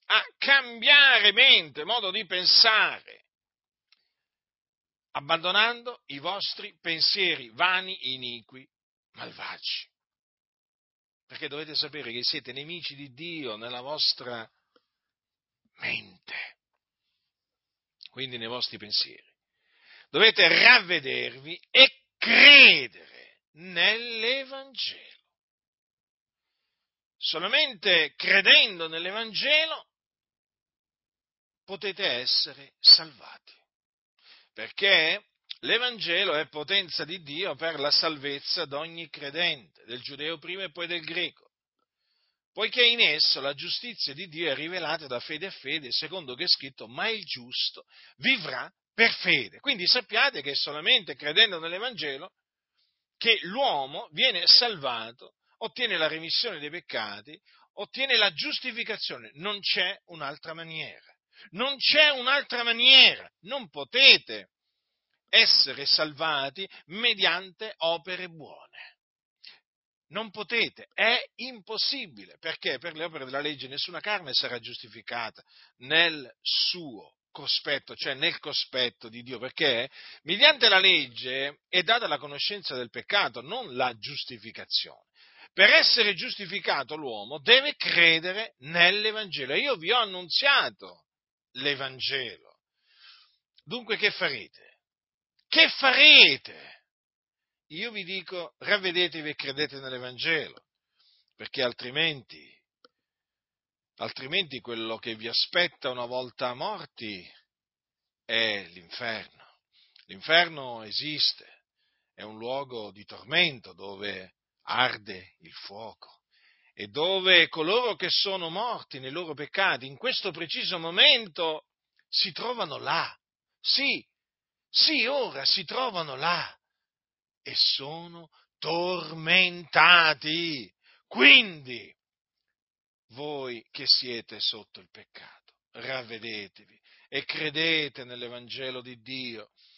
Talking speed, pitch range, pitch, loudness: 100 wpm, 130-200 Hz, 165 Hz, -22 LUFS